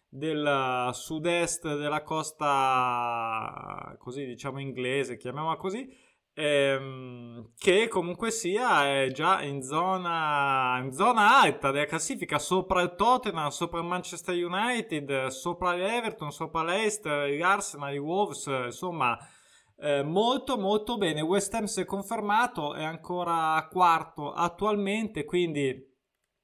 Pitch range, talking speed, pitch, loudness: 140-185 Hz, 120 wpm, 160 Hz, -28 LUFS